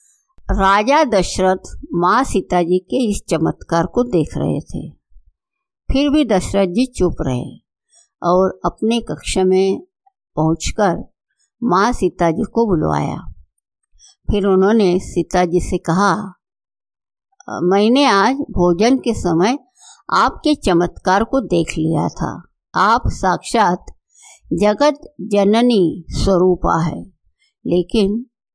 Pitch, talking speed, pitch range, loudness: 195 Hz, 110 wpm, 180-245 Hz, -17 LUFS